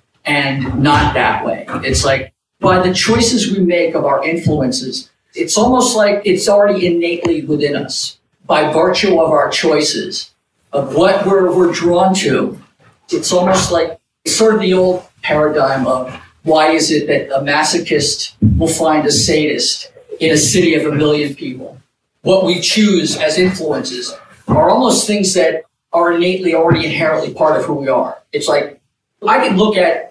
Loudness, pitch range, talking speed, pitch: -13 LUFS, 150-190 Hz, 165 wpm, 170 Hz